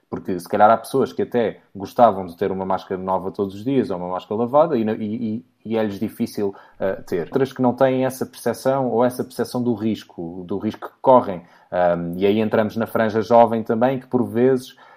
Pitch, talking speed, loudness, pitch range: 110 Hz, 215 wpm, -21 LUFS, 100-125 Hz